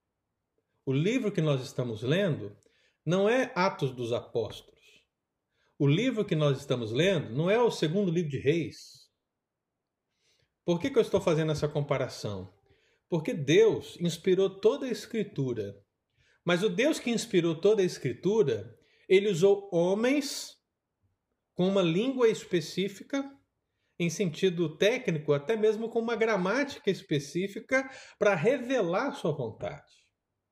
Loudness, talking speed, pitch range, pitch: -29 LUFS, 130 wpm, 145-225 Hz, 190 Hz